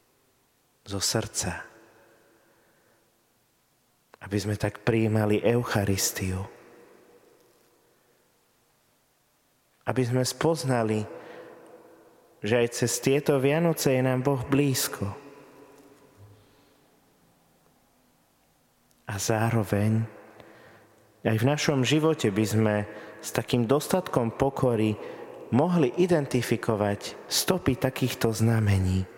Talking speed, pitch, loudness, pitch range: 75 wpm, 120 Hz, -26 LUFS, 105-140 Hz